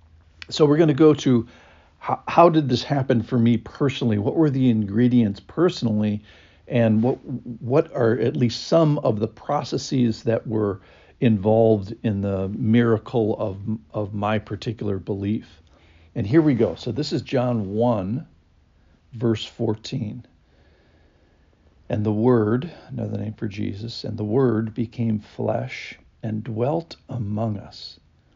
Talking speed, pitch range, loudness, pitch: 140 wpm, 100-125 Hz, -22 LUFS, 115 Hz